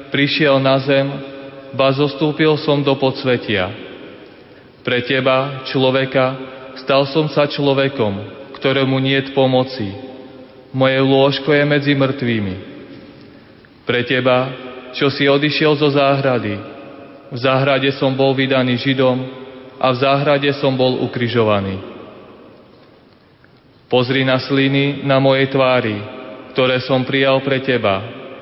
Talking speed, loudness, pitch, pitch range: 110 wpm, -16 LUFS, 135 Hz, 130-140 Hz